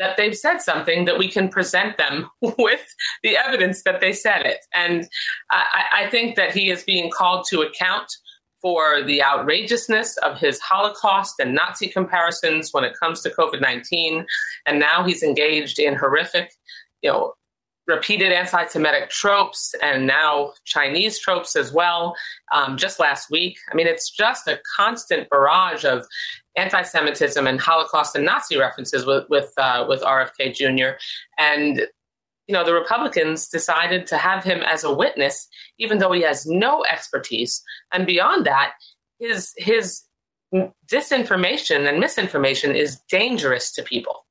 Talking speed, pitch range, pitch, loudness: 155 wpm, 150-200 Hz, 175 Hz, -19 LUFS